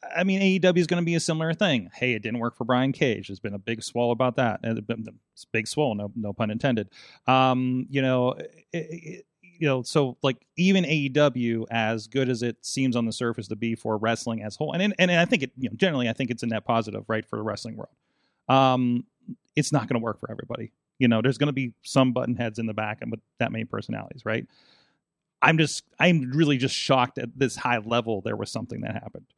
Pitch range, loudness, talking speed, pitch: 115-150 Hz, -25 LUFS, 240 wpm, 125 Hz